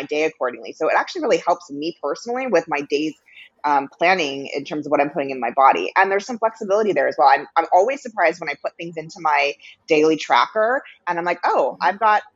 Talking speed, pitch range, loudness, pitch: 235 wpm, 145-195 Hz, -20 LUFS, 165 Hz